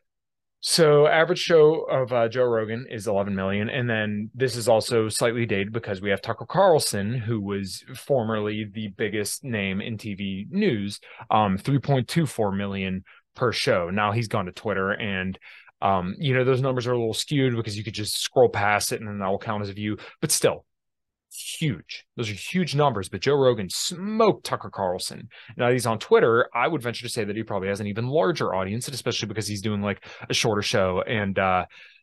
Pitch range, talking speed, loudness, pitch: 100-130 Hz, 200 wpm, -24 LUFS, 115 Hz